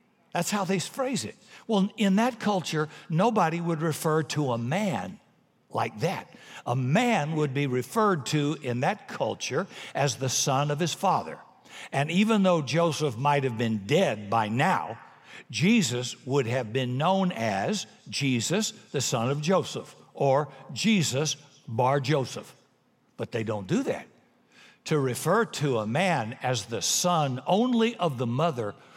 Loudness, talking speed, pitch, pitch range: -27 LUFS, 155 wpm, 155 Hz, 135-190 Hz